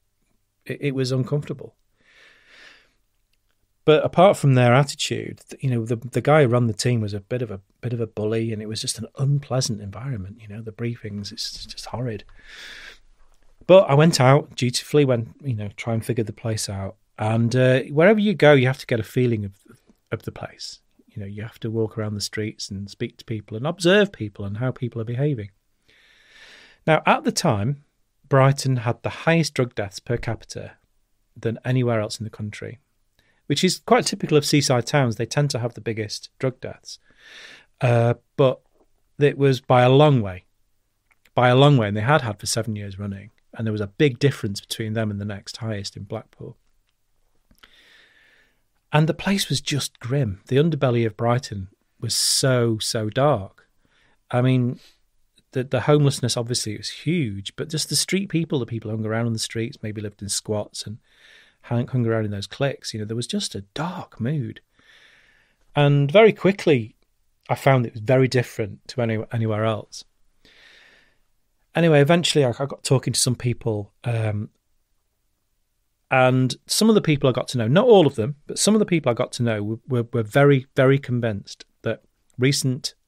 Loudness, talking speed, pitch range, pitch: -21 LUFS, 190 wpm, 110-140 Hz, 120 Hz